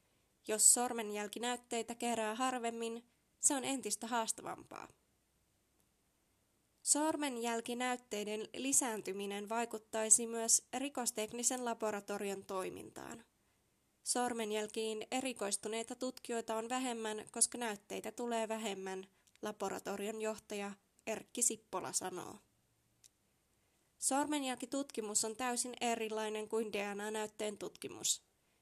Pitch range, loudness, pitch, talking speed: 210-245 Hz, -37 LUFS, 225 Hz, 75 wpm